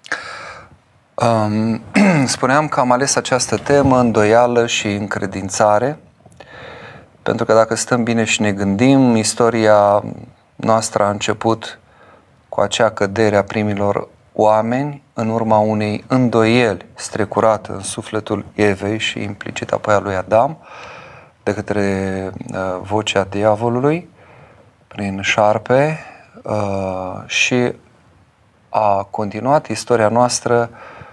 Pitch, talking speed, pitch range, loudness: 110 Hz, 105 wpm, 105-120 Hz, -16 LUFS